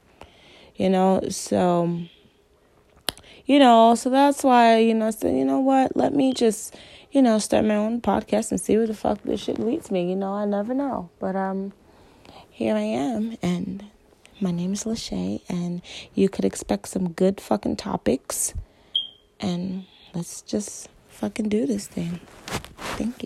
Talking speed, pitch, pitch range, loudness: 165 wpm, 205 Hz, 185-230 Hz, -23 LUFS